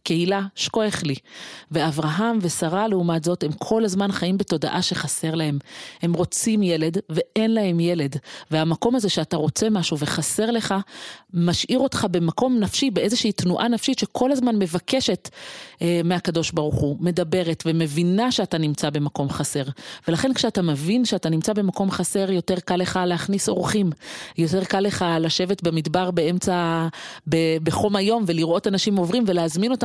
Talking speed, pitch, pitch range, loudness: 145 wpm, 180 Hz, 165-210 Hz, -22 LUFS